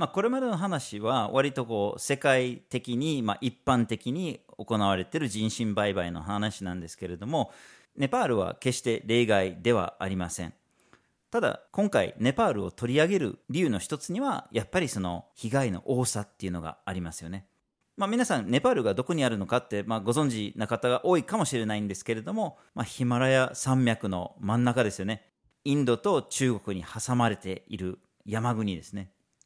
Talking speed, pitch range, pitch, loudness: 365 characters per minute, 100-130 Hz, 115 Hz, -28 LUFS